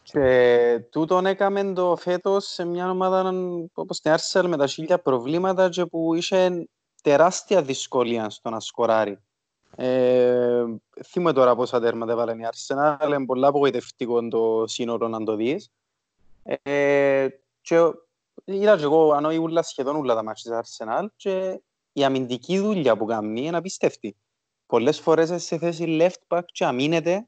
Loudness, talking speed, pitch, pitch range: -22 LUFS, 145 wpm, 145 Hz, 120-175 Hz